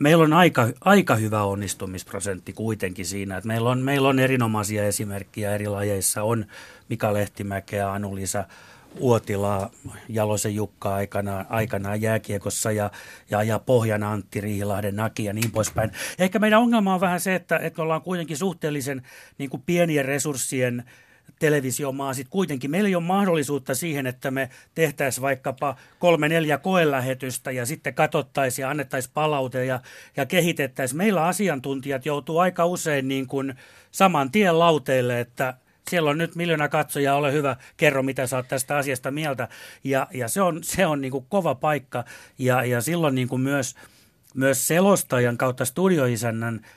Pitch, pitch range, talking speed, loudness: 135 Hz, 110-155 Hz, 150 wpm, -23 LUFS